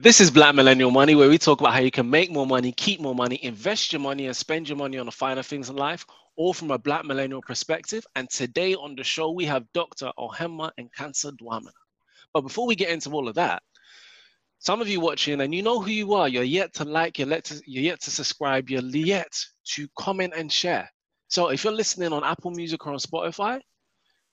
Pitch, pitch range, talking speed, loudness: 150 Hz, 135-175 Hz, 230 wpm, -23 LUFS